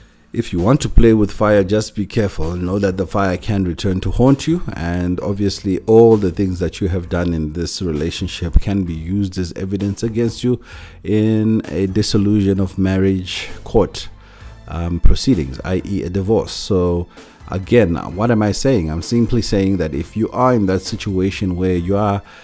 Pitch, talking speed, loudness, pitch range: 95 Hz, 180 wpm, -17 LUFS, 90-110 Hz